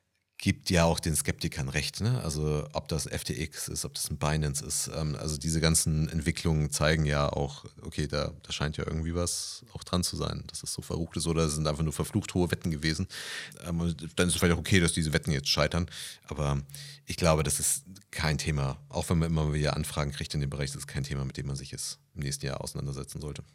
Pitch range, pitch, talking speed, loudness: 75-85 Hz, 80 Hz, 240 wpm, -30 LUFS